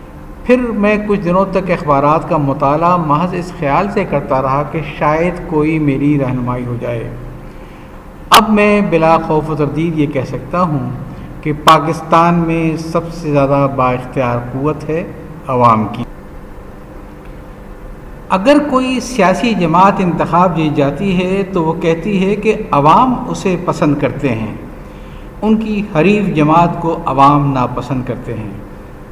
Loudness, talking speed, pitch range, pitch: -13 LUFS, 145 wpm, 140-180 Hz, 160 Hz